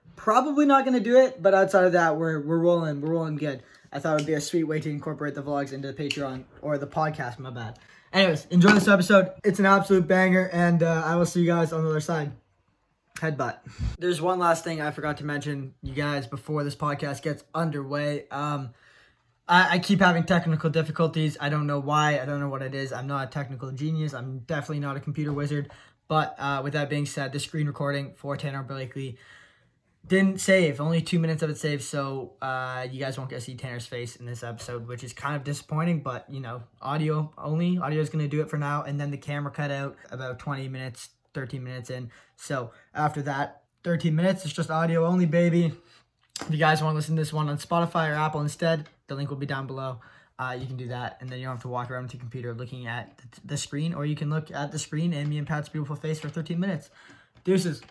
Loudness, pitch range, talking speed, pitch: -26 LUFS, 135-165 Hz, 235 wpm, 150 Hz